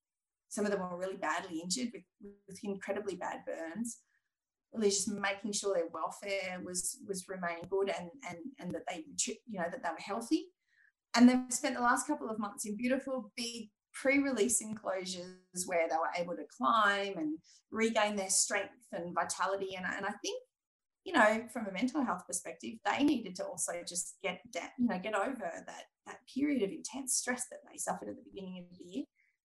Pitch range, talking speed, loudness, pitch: 185-250 Hz, 200 wpm, -35 LUFS, 205 Hz